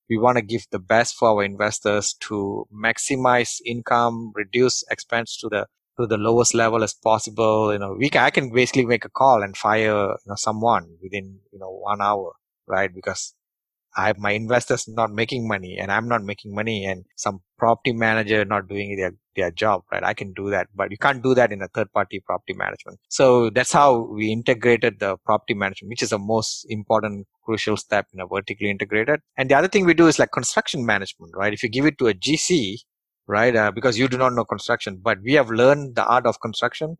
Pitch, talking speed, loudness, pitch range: 110 Hz, 215 wpm, -21 LUFS, 105-125 Hz